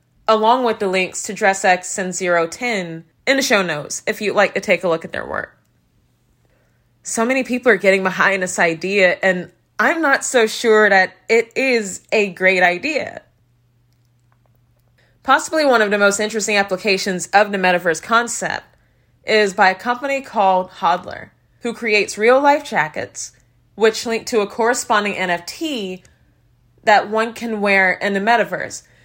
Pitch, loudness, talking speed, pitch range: 200 Hz, -17 LUFS, 160 wpm, 180-225 Hz